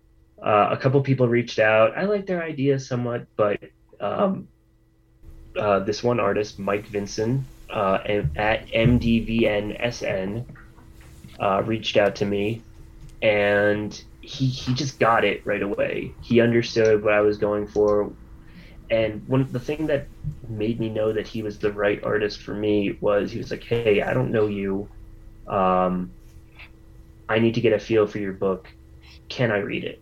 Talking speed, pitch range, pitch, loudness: 165 wpm, 100-120 Hz, 110 Hz, -23 LUFS